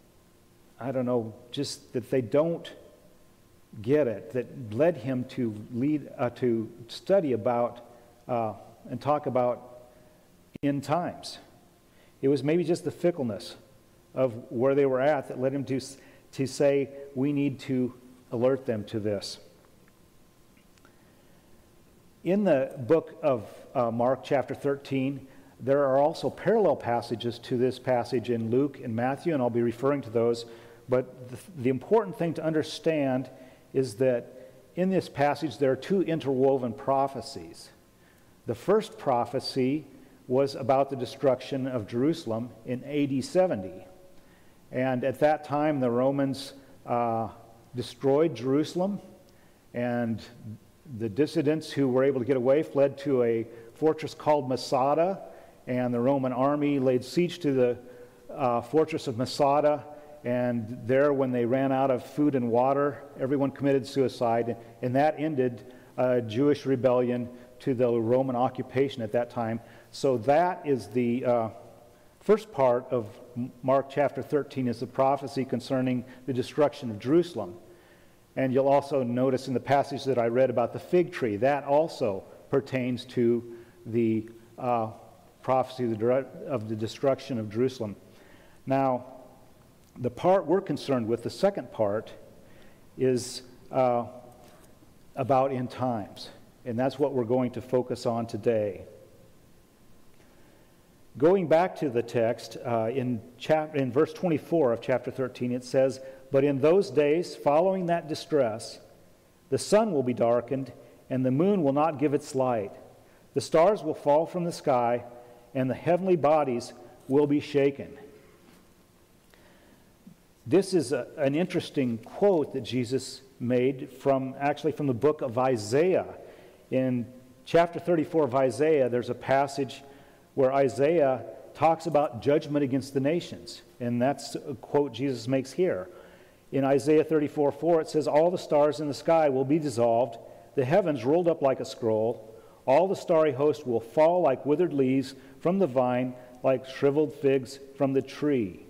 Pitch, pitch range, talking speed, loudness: 130 Hz, 120-145 Hz, 150 wpm, -27 LUFS